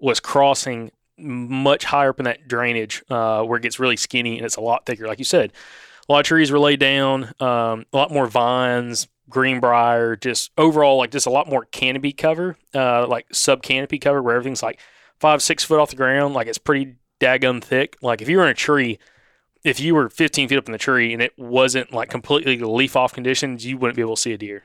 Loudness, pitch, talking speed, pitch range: -19 LUFS, 130 Hz, 235 wpm, 120-140 Hz